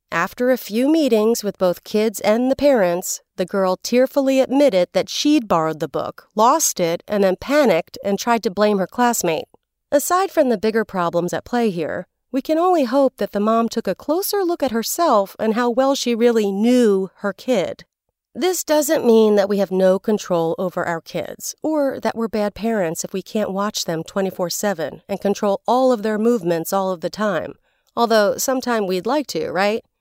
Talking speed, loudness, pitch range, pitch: 195 wpm, -19 LUFS, 190-255 Hz, 220 Hz